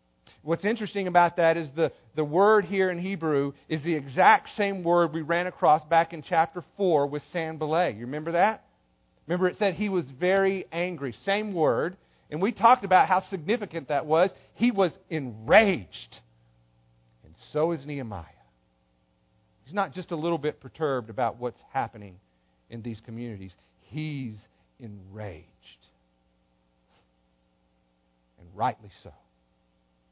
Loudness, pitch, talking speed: -26 LUFS, 145 Hz, 140 wpm